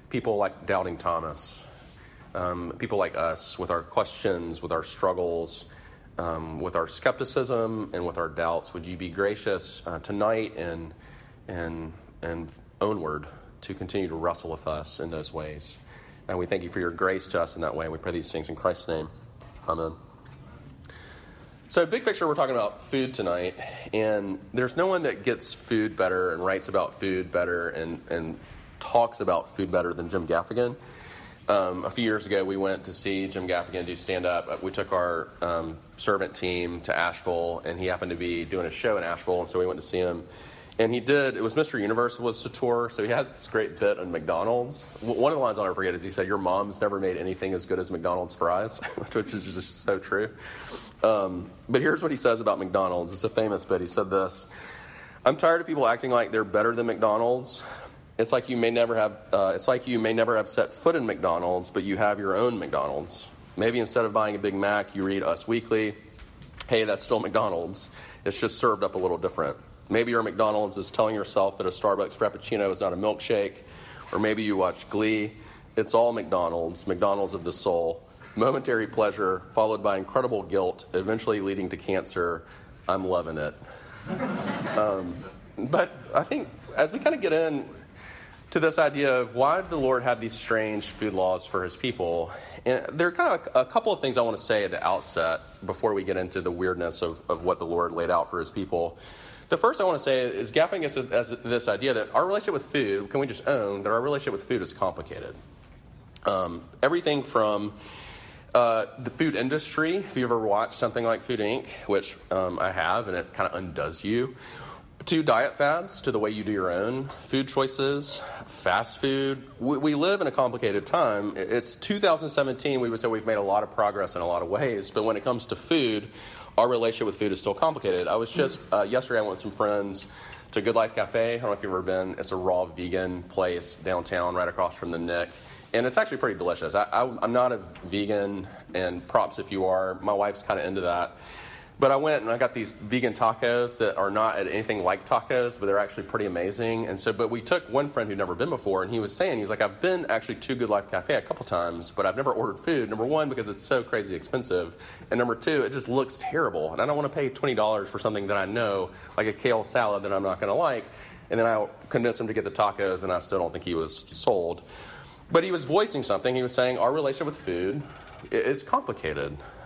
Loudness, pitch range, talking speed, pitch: -27 LUFS, 90-120 Hz, 215 wpm, 105 Hz